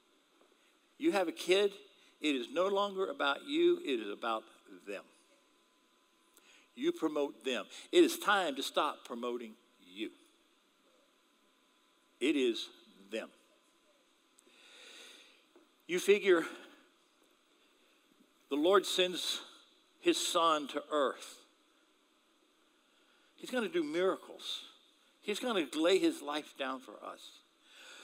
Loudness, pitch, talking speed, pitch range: -34 LUFS, 330 Hz, 105 wpm, 285-350 Hz